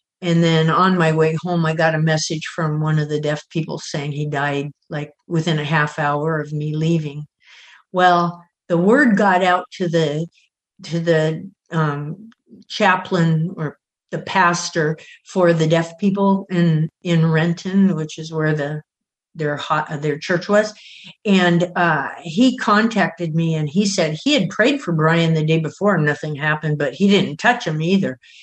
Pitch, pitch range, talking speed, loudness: 165 Hz, 155-180 Hz, 170 wpm, -18 LUFS